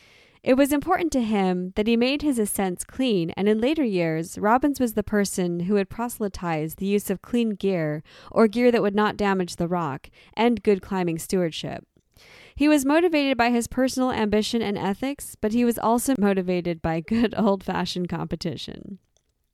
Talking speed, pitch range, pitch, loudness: 175 wpm, 180-240 Hz, 210 Hz, -23 LUFS